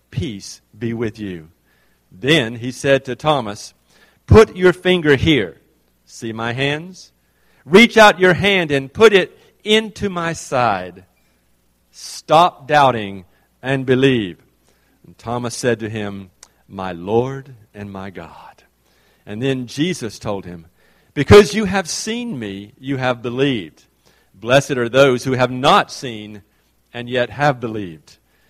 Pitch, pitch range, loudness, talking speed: 120 Hz, 95-140 Hz, -16 LUFS, 135 wpm